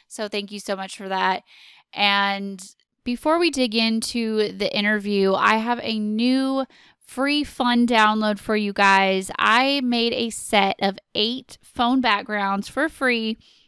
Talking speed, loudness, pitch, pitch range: 150 wpm, -21 LUFS, 215 Hz, 200-245 Hz